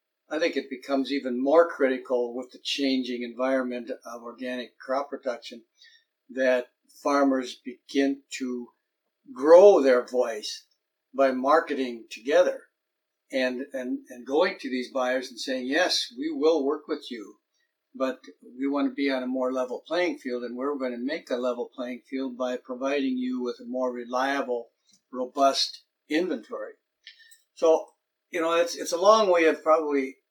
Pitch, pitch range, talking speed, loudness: 130 Hz, 125-160 Hz, 155 wpm, -26 LUFS